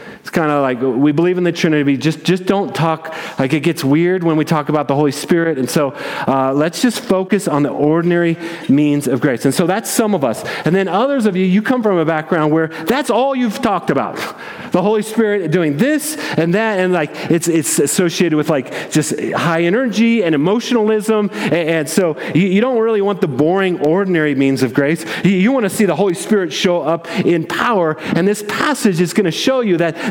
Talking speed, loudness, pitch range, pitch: 215 wpm, -15 LUFS, 155-210 Hz, 175 Hz